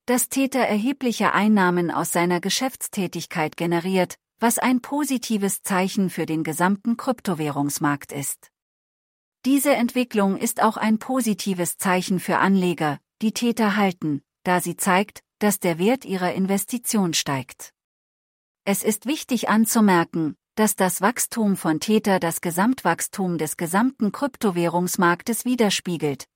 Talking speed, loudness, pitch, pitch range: 120 wpm, -22 LUFS, 195 Hz, 175-225 Hz